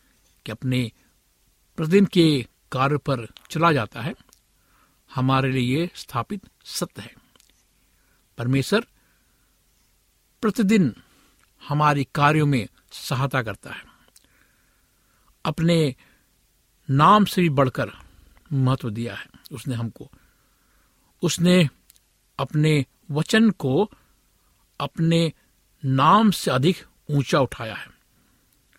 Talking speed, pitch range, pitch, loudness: 90 wpm, 130-170 Hz, 140 Hz, -22 LUFS